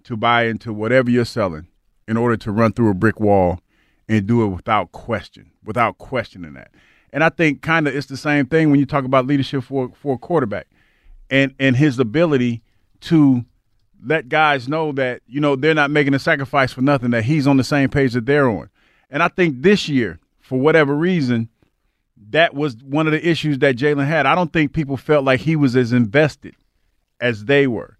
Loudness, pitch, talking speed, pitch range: -18 LUFS, 135 Hz, 210 wpm, 120-150 Hz